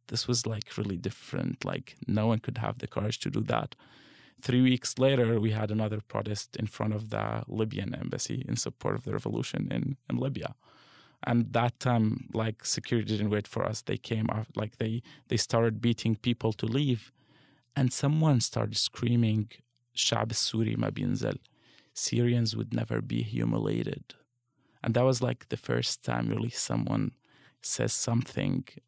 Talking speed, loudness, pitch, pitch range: 165 wpm, -30 LUFS, 120 Hz, 110-130 Hz